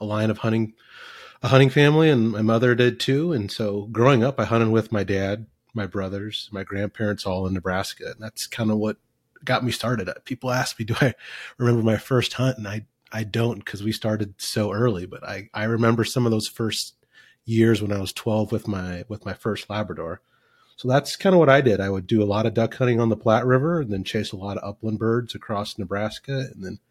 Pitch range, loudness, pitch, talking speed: 105-120 Hz, -23 LUFS, 110 Hz, 230 wpm